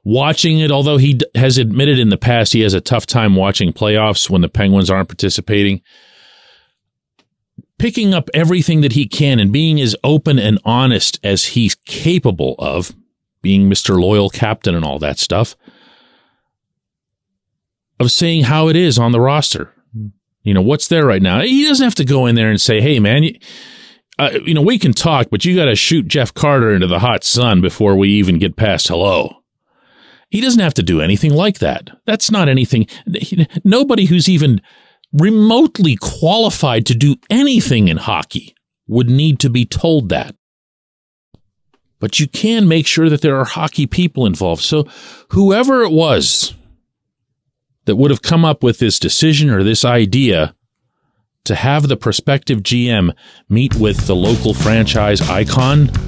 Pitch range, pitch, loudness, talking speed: 105-155 Hz, 125 Hz, -13 LUFS, 170 wpm